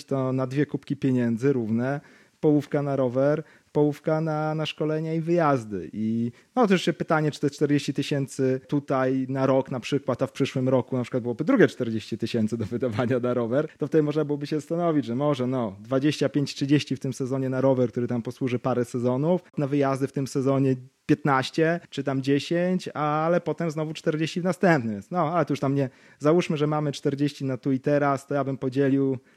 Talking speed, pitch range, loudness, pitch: 195 wpm, 130-150 Hz, -25 LUFS, 140 Hz